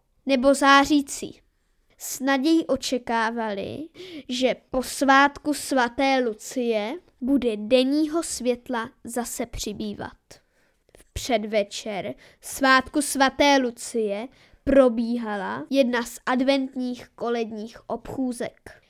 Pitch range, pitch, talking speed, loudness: 235-275 Hz, 255 Hz, 80 wpm, -23 LUFS